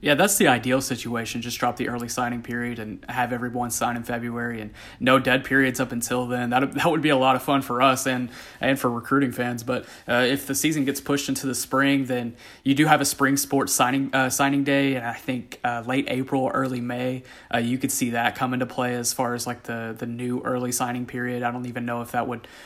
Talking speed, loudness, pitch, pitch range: 245 wpm, -24 LUFS, 125 Hz, 120-135 Hz